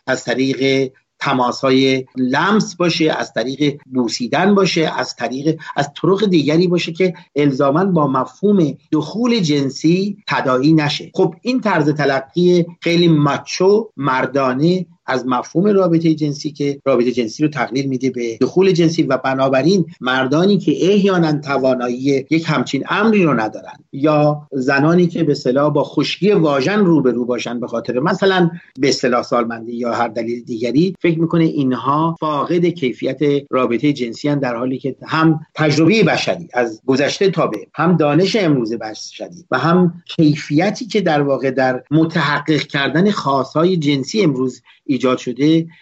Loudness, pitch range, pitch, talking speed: -16 LUFS, 130-170 Hz, 150 Hz, 150 wpm